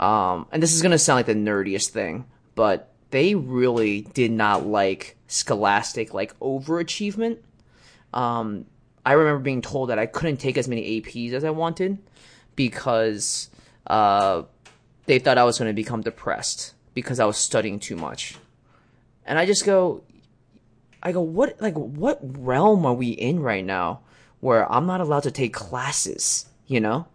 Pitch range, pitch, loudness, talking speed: 110-165 Hz, 125 Hz, -23 LUFS, 165 wpm